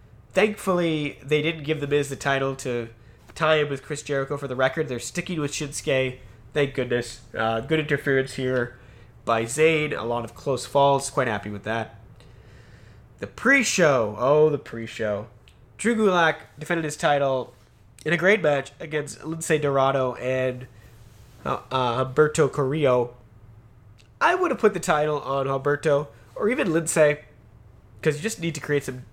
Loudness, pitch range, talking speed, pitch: -24 LUFS, 115-150 Hz, 165 wpm, 135 Hz